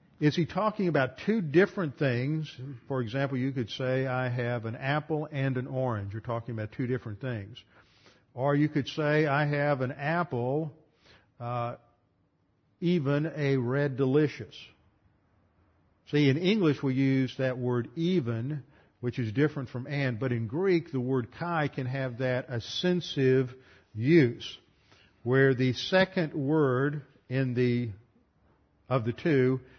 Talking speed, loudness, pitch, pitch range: 145 wpm, -29 LUFS, 130 Hz, 120-150 Hz